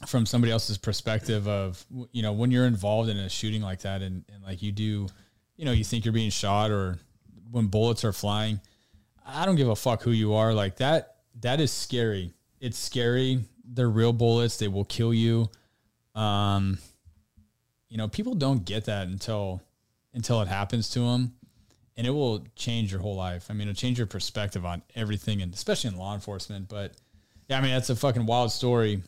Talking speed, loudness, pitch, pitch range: 200 wpm, -28 LUFS, 110 Hz, 100-120 Hz